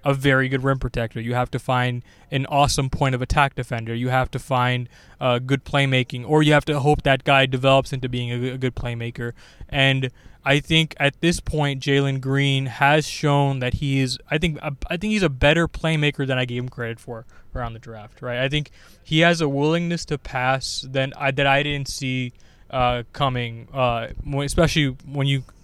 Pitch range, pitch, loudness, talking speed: 125-145 Hz, 135 Hz, -21 LUFS, 205 wpm